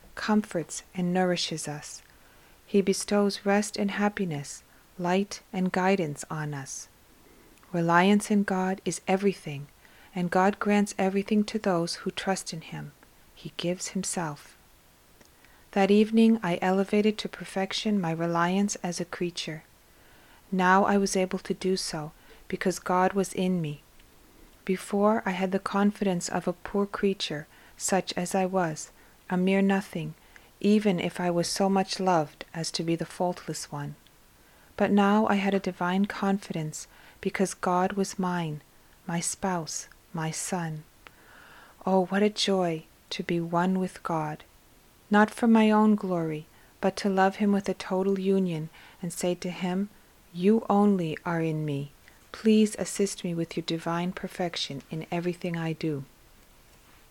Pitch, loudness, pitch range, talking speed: 185 Hz, -27 LUFS, 170-195 Hz, 150 wpm